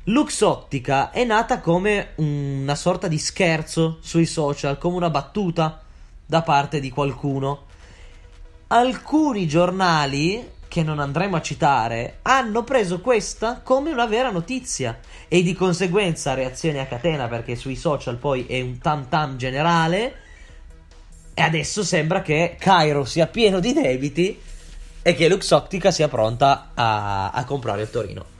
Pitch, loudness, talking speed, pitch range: 155 Hz, -21 LUFS, 135 wpm, 130-185 Hz